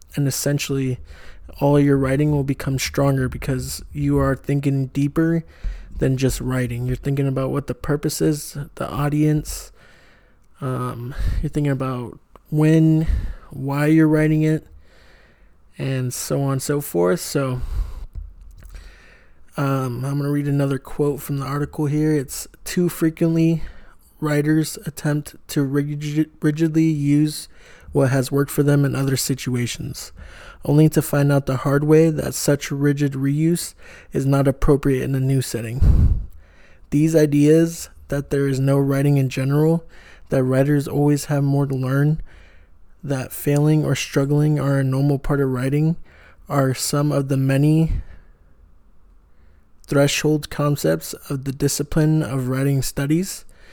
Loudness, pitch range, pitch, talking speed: -20 LUFS, 130-150 Hz, 140 Hz, 140 wpm